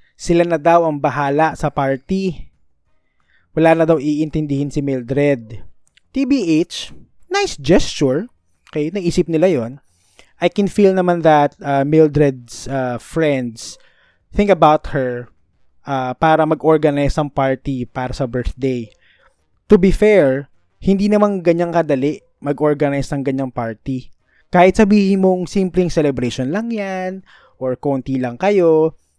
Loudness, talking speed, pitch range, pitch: -16 LUFS, 125 wpm, 135-180 Hz, 150 Hz